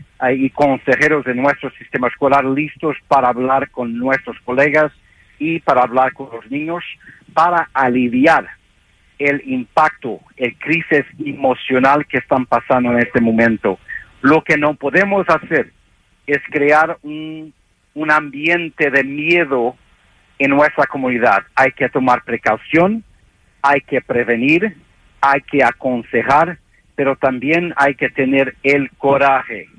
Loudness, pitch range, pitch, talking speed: -15 LUFS, 125-150 Hz, 140 Hz, 125 wpm